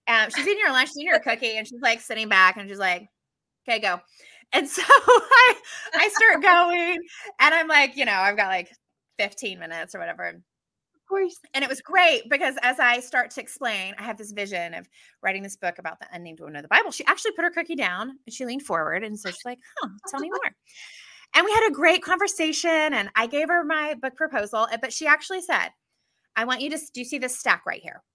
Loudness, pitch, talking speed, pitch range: -21 LUFS, 270 Hz, 235 wpm, 220-345 Hz